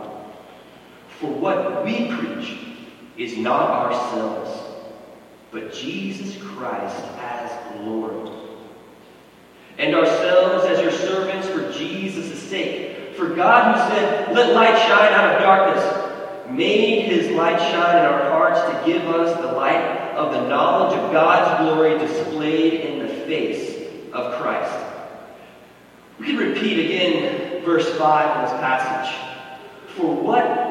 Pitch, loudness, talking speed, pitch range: 165 Hz, -19 LUFS, 125 wpm, 130-195 Hz